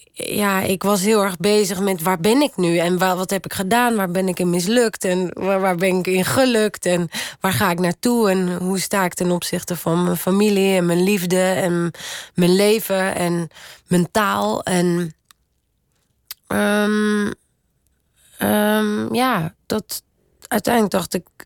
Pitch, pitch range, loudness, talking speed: 190 Hz, 180-210 Hz, -19 LUFS, 160 wpm